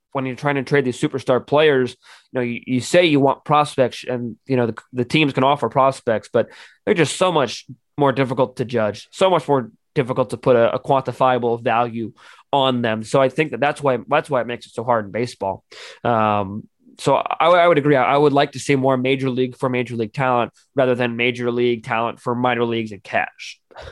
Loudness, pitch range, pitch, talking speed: -19 LUFS, 120-140 Hz, 130 Hz, 225 wpm